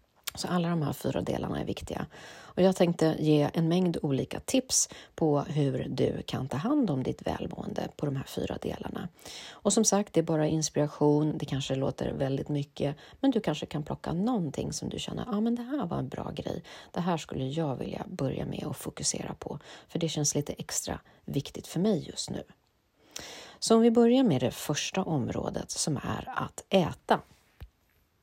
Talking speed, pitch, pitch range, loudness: 195 wpm, 155 Hz, 145-185 Hz, -30 LUFS